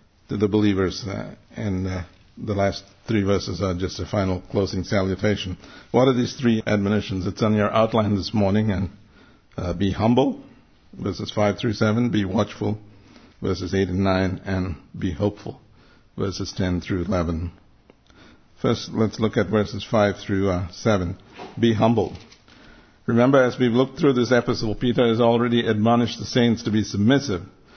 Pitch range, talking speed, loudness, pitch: 95-115 Hz, 160 wpm, -22 LUFS, 105 Hz